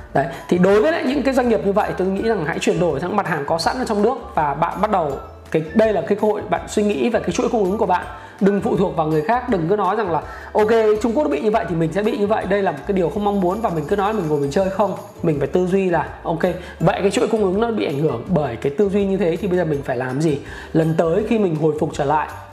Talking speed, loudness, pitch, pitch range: 320 wpm, -19 LUFS, 200 Hz, 170-215 Hz